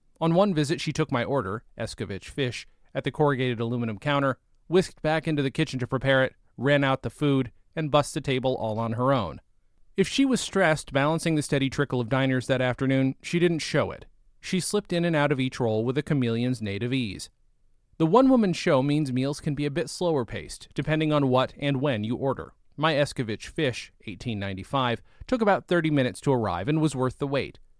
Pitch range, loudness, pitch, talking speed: 120-155 Hz, -26 LUFS, 135 Hz, 205 wpm